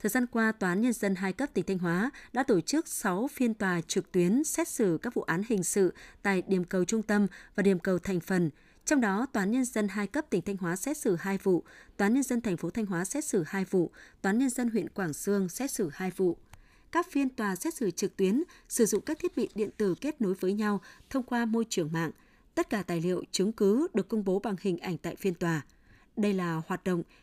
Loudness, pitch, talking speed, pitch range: -30 LUFS, 200 Hz, 260 wpm, 185-235 Hz